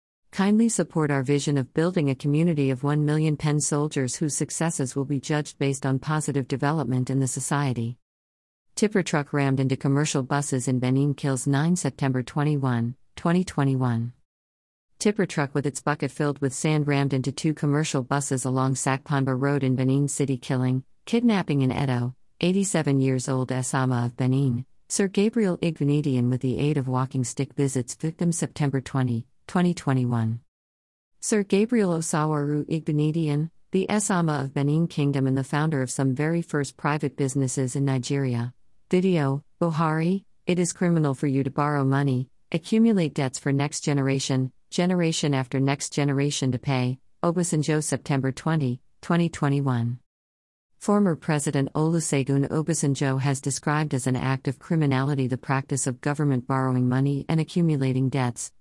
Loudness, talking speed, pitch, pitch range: -25 LUFS, 150 wpm, 140 Hz, 130-155 Hz